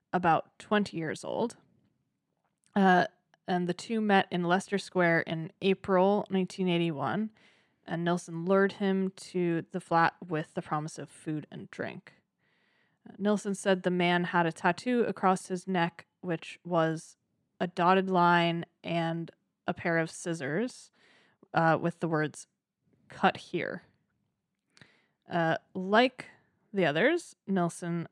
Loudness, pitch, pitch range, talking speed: -30 LUFS, 175 Hz, 165-195 Hz, 130 wpm